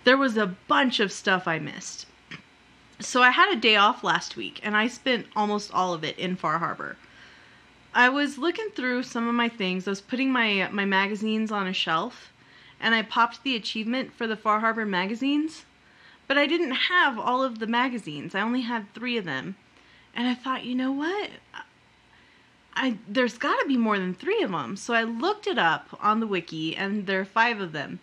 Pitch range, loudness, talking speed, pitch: 200-260 Hz, -25 LUFS, 205 wpm, 230 Hz